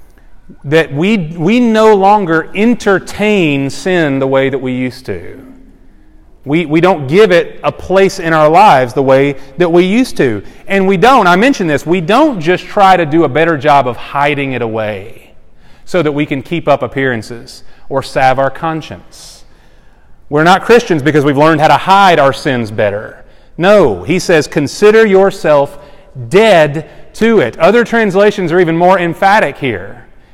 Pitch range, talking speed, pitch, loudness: 140-195 Hz, 170 wpm, 160 Hz, -10 LUFS